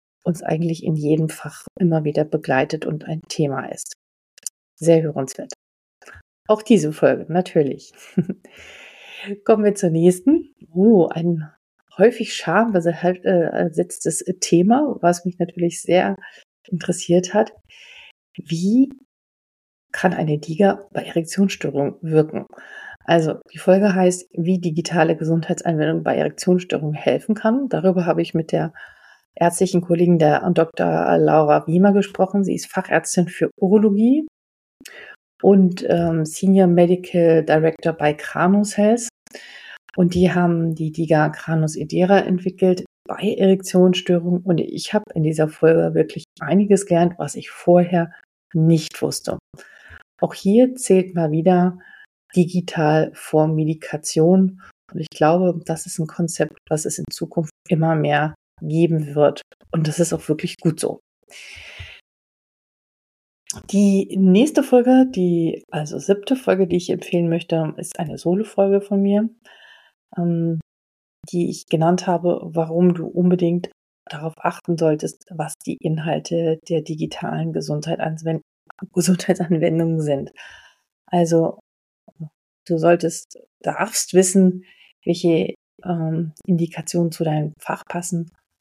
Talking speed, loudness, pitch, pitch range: 120 wpm, -19 LUFS, 175 Hz, 160-190 Hz